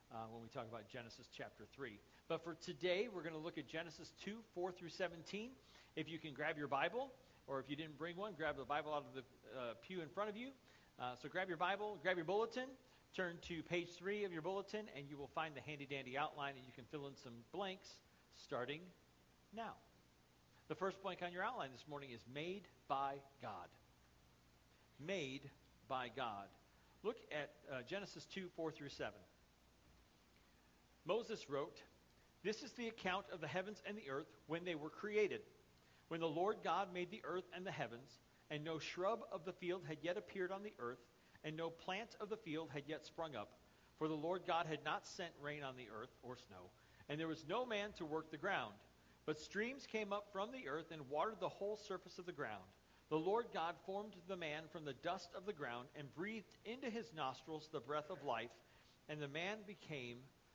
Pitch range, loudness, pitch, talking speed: 135-190 Hz, -47 LUFS, 160 Hz, 205 wpm